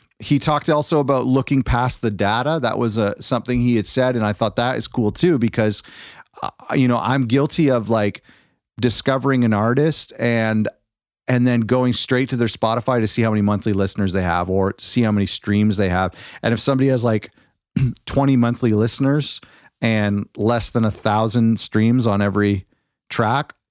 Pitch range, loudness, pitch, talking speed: 105-130 Hz, -19 LUFS, 115 Hz, 185 wpm